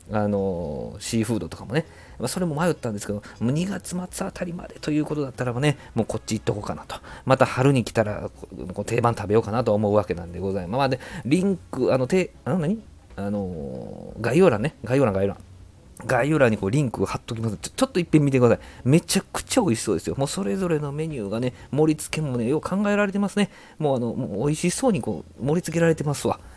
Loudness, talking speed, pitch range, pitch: -24 LUFS, 475 characters per minute, 105-160 Hz, 125 Hz